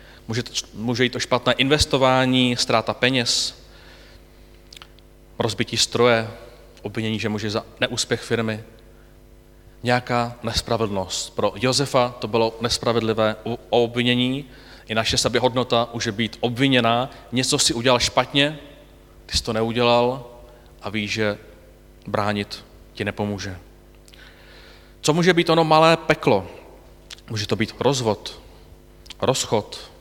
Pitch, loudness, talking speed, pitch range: 115 Hz, -21 LUFS, 110 wpm, 100-125 Hz